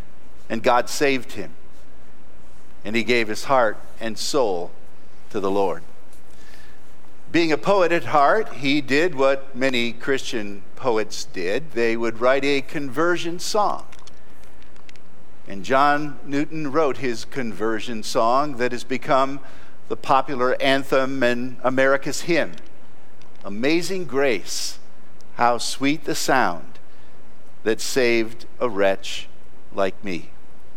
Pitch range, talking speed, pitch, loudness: 115-145 Hz, 115 wpm, 130 Hz, -22 LUFS